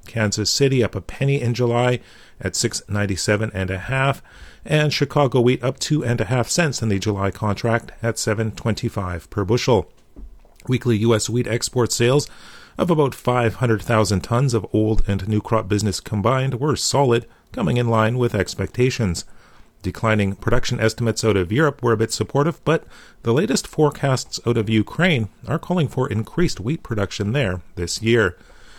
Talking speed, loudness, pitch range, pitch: 175 wpm, -20 LUFS, 105-130 Hz, 115 Hz